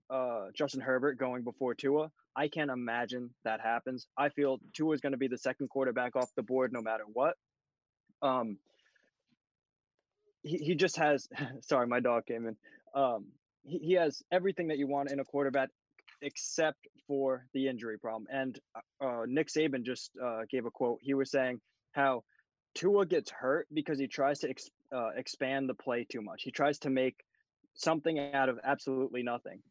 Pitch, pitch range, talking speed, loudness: 135 Hz, 125-150 Hz, 180 wpm, -34 LUFS